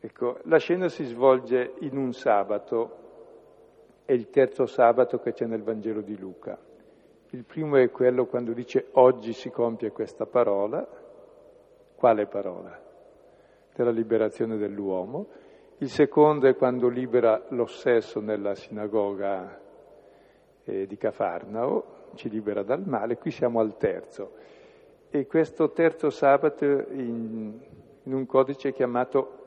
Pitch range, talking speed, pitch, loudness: 115-160 Hz, 125 wpm, 130 Hz, -26 LUFS